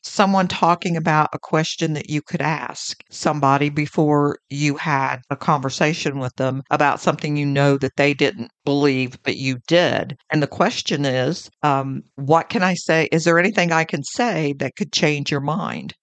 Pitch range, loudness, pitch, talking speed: 140-165 Hz, -20 LUFS, 150 Hz, 180 wpm